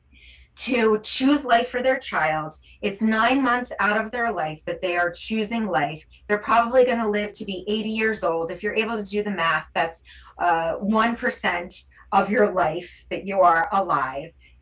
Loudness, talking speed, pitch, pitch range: -23 LUFS, 180 wpm, 210 Hz, 170-230 Hz